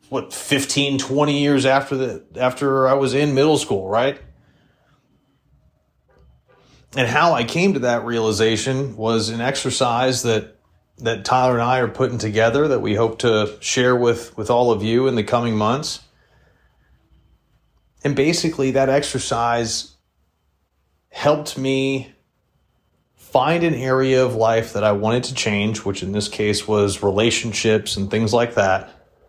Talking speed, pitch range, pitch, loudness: 145 wpm, 110-135 Hz, 120 Hz, -19 LUFS